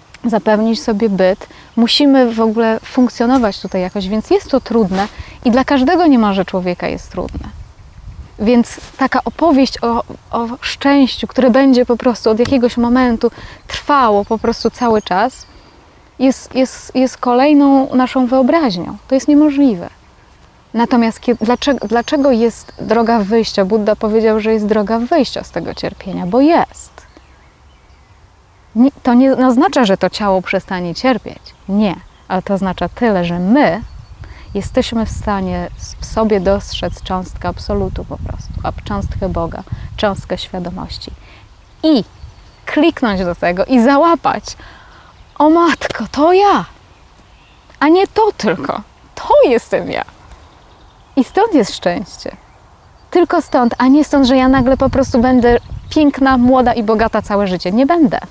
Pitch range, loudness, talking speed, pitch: 205-265 Hz, -14 LUFS, 140 wpm, 235 Hz